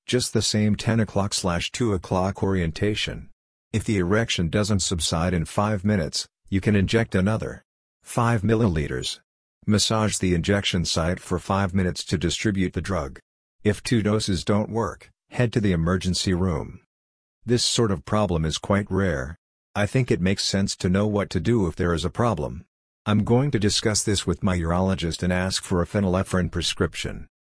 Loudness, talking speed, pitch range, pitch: -24 LUFS, 175 wpm, 90-110 Hz, 100 Hz